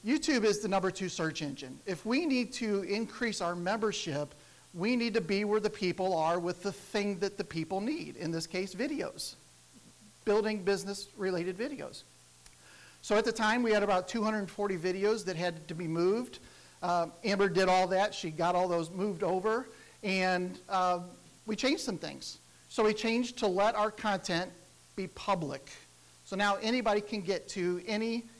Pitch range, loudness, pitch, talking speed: 180-215 Hz, -32 LUFS, 200 Hz, 180 wpm